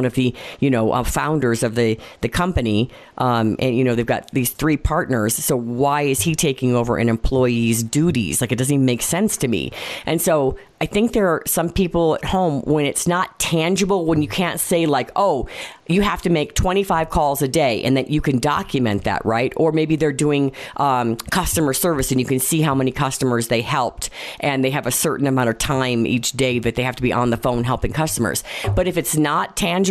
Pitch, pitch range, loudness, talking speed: 135 Hz, 125-160 Hz, -19 LUFS, 225 wpm